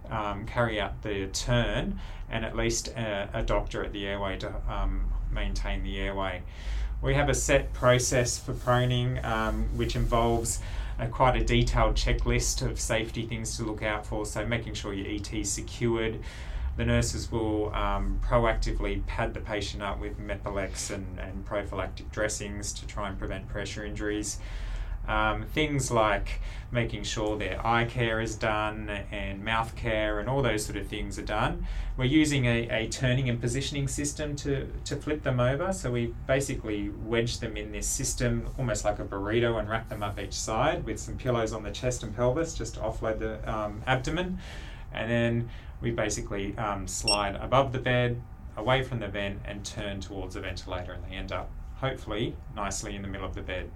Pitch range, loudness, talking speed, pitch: 100-120 Hz, -30 LUFS, 185 wpm, 110 Hz